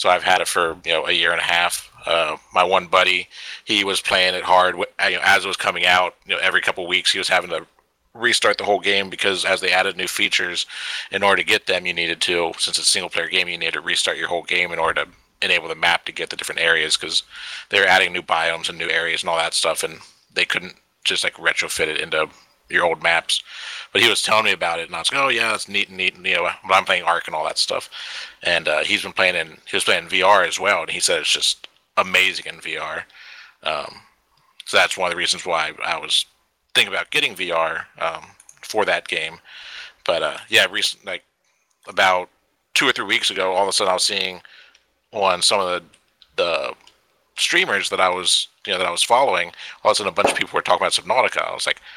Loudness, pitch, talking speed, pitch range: -19 LUFS, 90 Hz, 250 wpm, 90-100 Hz